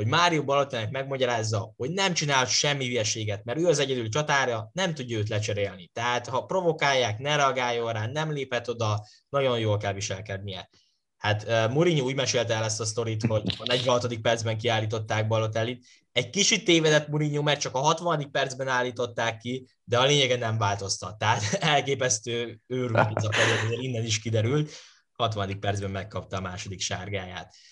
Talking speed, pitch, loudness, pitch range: 160 wpm, 120 Hz, -26 LUFS, 110-135 Hz